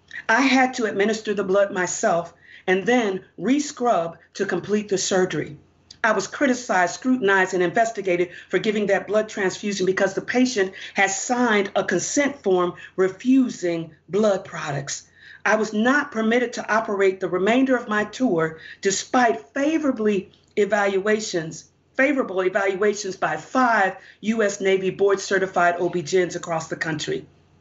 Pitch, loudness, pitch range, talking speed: 195 Hz, -22 LUFS, 185-225 Hz, 135 wpm